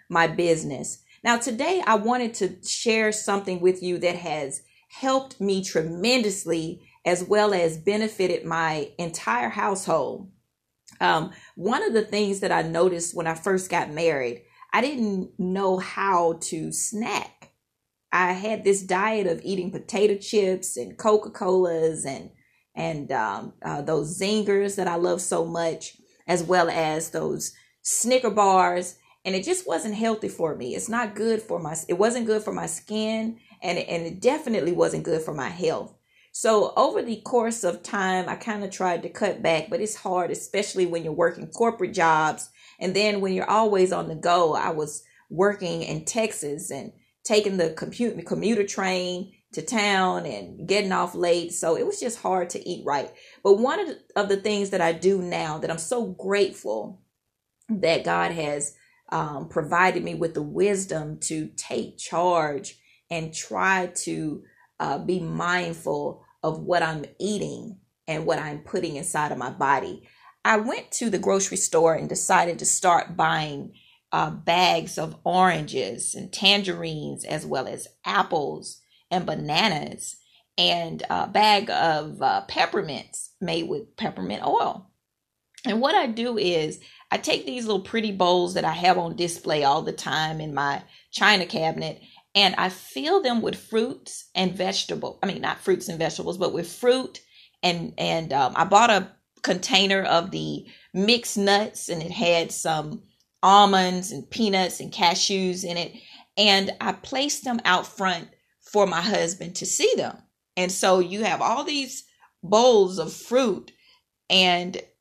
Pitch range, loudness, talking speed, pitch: 170-210 Hz, -24 LUFS, 165 wpm, 185 Hz